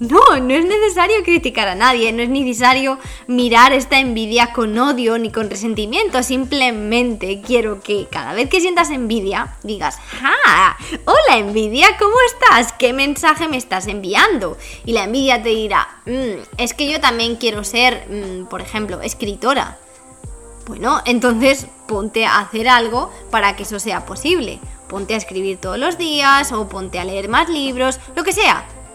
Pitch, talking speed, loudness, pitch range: 245 Hz, 165 wpm, -15 LUFS, 215-275 Hz